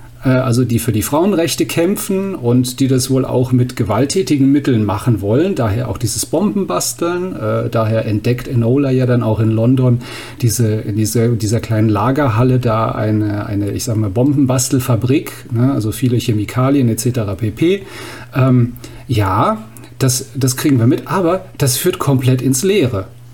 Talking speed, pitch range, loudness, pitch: 145 wpm, 115-135 Hz, -15 LUFS, 125 Hz